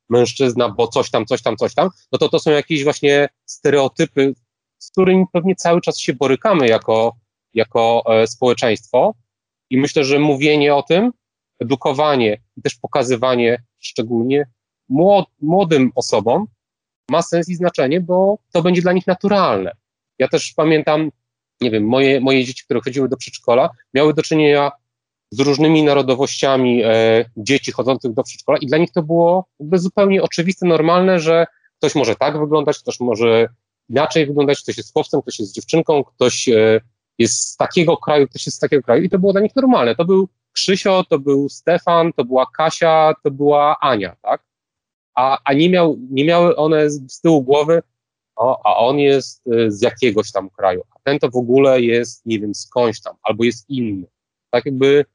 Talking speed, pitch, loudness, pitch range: 175 wpm, 140 Hz, -16 LUFS, 120-165 Hz